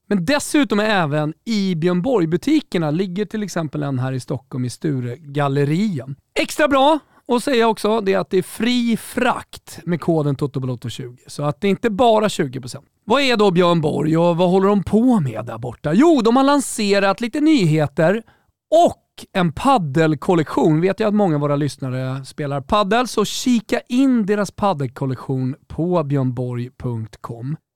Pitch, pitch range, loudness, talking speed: 175 Hz, 145-220 Hz, -19 LUFS, 165 wpm